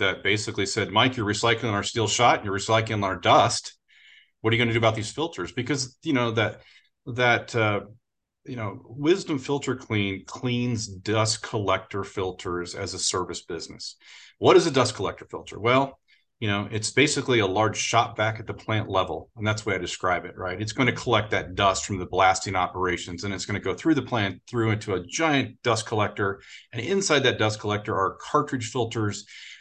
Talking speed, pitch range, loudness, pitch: 205 wpm, 100-125 Hz, -25 LUFS, 110 Hz